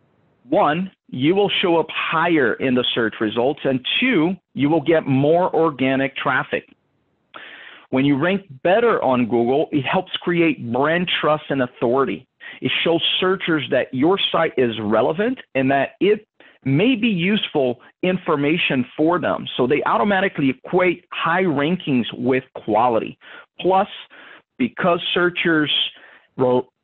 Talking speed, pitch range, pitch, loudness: 135 wpm, 135-185 Hz, 160 Hz, -19 LUFS